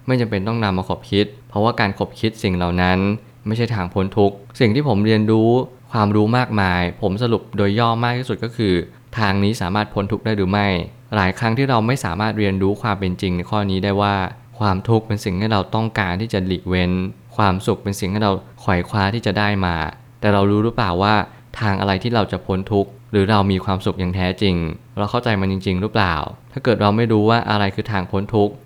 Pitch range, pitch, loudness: 95-115 Hz, 105 Hz, -19 LUFS